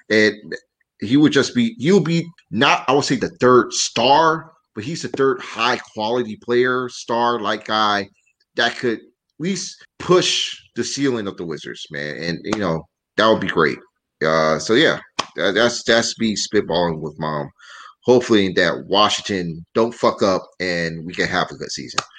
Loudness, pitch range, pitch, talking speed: -19 LUFS, 95-125 Hz, 110 Hz, 165 wpm